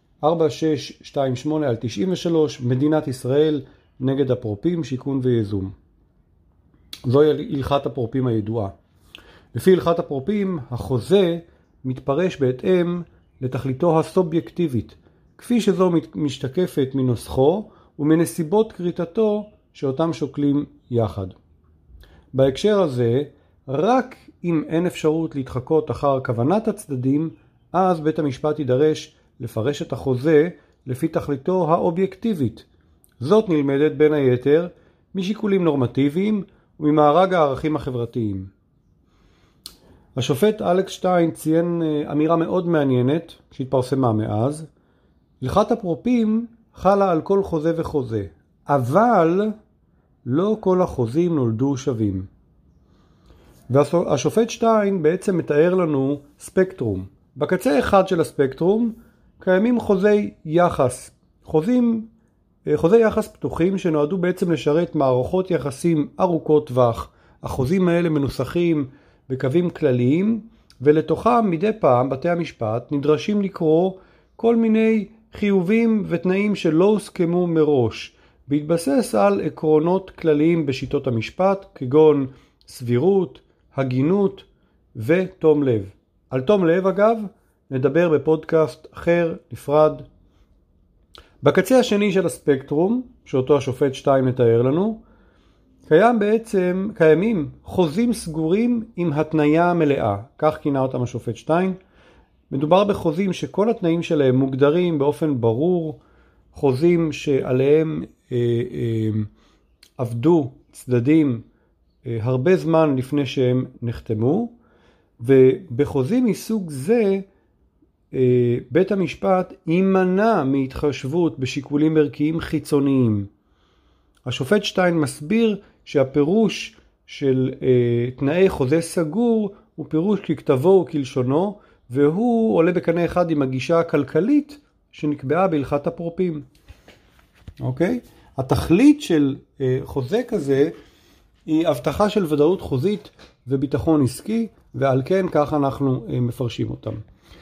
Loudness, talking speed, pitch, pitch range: -20 LUFS, 95 wpm, 155 Hz, 130-185 Hz